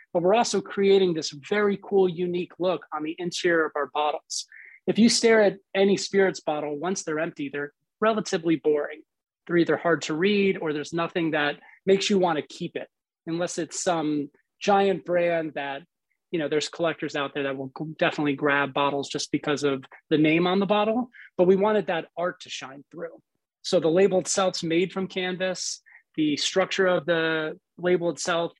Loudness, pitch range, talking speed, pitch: -25 LUFS, 155-190 Hz, 185 wpm, 175 Hz